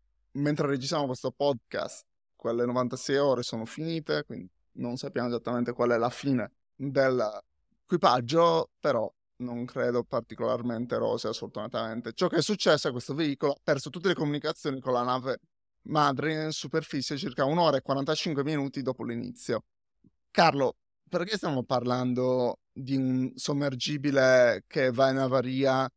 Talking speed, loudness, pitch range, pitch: 140 wpm, -28 LUFS, 125-150 Hz, 135 Hz